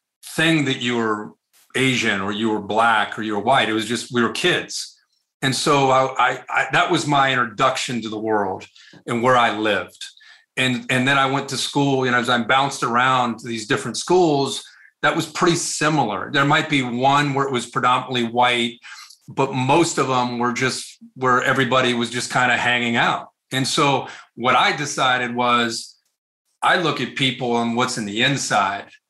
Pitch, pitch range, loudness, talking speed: 125 Hz, 120-140 Hz, -19 LUFS, 195 wpm